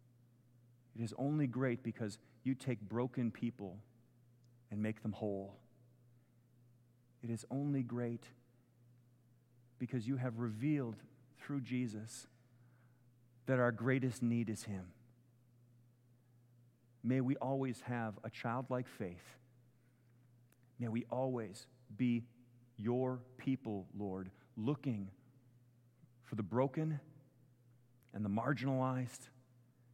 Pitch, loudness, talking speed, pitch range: 120 Hz, -41 LUFS, 100 wpm, 120-125 Hz